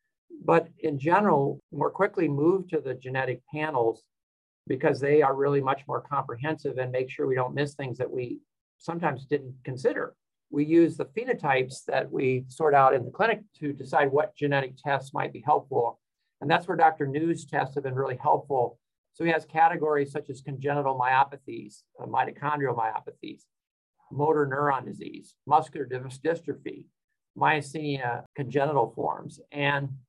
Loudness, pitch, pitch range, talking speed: -27 LUFS, 145 Hz, 135-160 Hz, 155 wpm